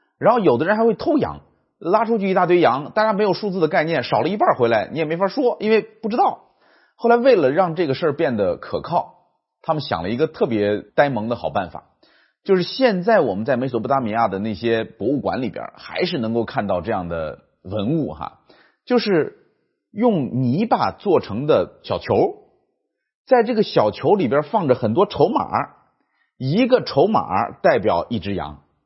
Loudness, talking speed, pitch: -20 LUFS, 275 characters per minute, 195 Hz